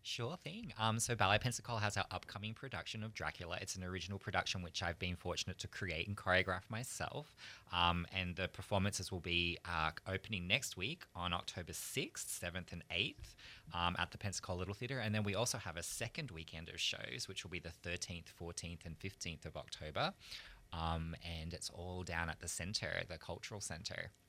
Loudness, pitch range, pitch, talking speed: -41 LUFS, 85-105 Hz, 95 Hz, 195 wpm